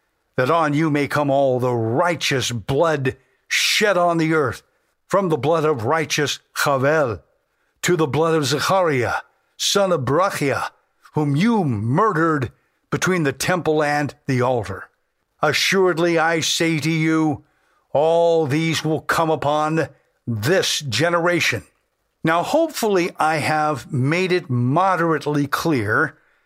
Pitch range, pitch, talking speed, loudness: 140-170 Hz, 155 Hz, 125 wpm, -19 LUFS